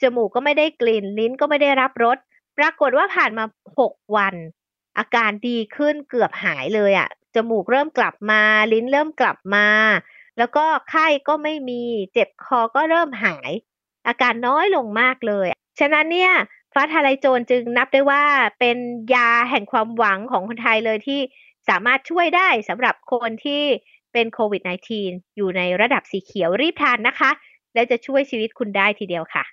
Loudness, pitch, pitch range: -19 LUFS, 245 Hz, 220-280 Hz